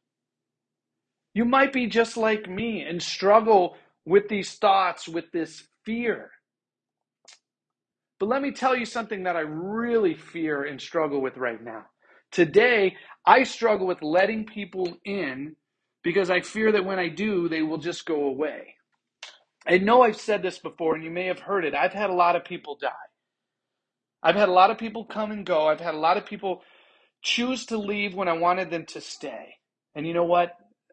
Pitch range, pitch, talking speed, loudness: 170-220 Hz, 190 Hz, 185 wpm, -24 LUFS